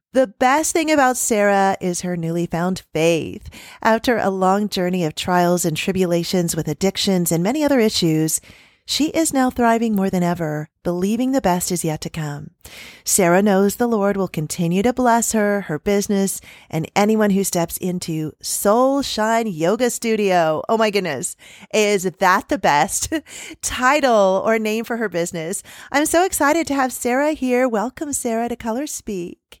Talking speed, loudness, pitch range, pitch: 170 wpm, -19 LUFS, 175-245 Hz, 200 Hz